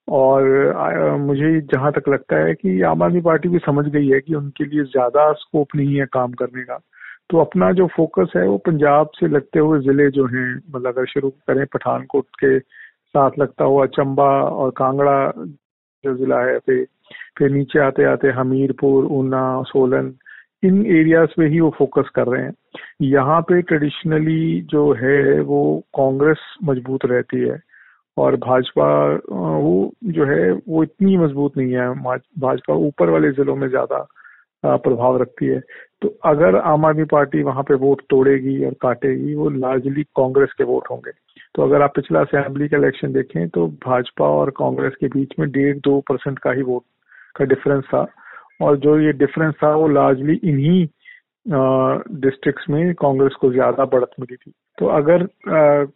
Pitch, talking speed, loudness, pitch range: 140 Hz, 170 wpm, -17 LUFS, 130-150 Hz